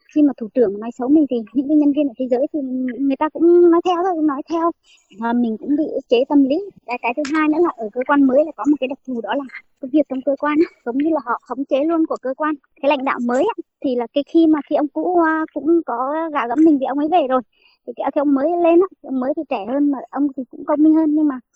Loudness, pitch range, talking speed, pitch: -18 LUFS, 260-315 Hz, 290 wpm, 290 Hz